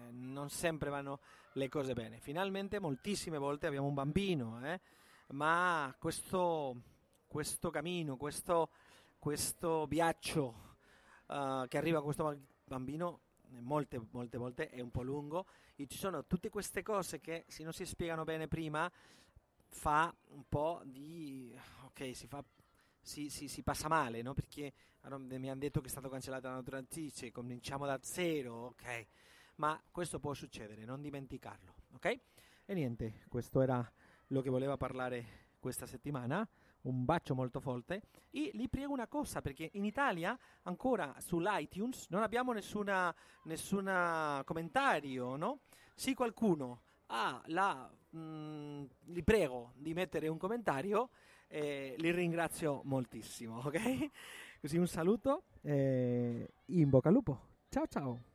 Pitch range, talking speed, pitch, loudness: 130-175 Hz, 145 wpm, 145 Hz, -39 LUFS